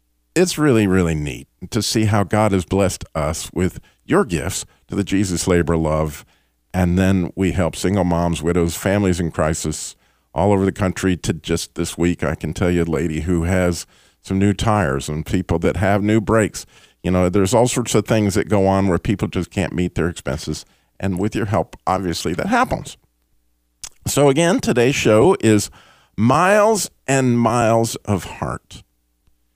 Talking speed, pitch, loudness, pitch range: 180 wpm, 95 Hz, -19 LUFS, 85-105 Hz